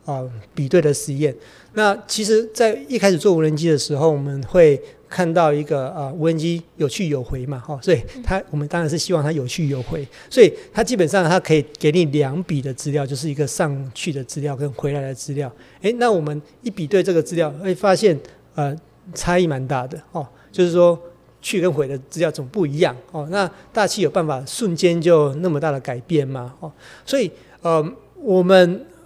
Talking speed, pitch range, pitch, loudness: 295 characters per minute, 145-180 Hz, 160 Hz, -19 LUFS